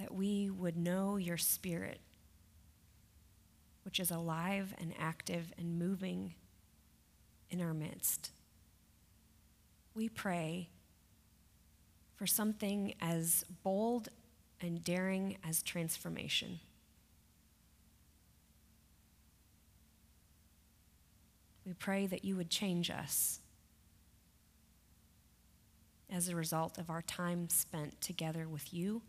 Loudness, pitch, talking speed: -38 LUFS, 120 Hz, 90 wpm